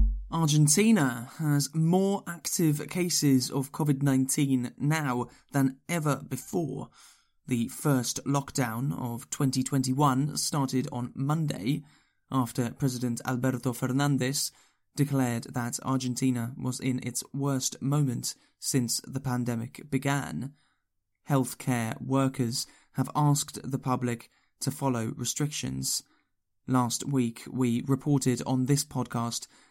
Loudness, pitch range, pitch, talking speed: -29 LUFS, 125-145 Hz, 130 Hz, 105 wpm